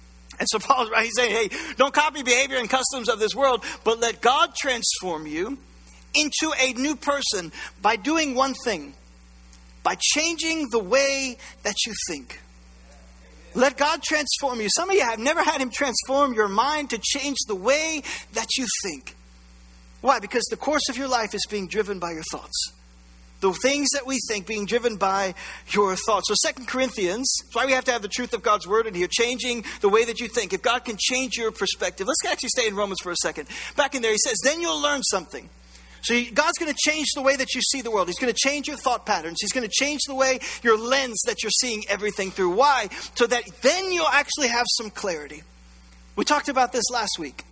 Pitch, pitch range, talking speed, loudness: 240 Hz, 200-275 Hz, 210 wpm, -22 LUFS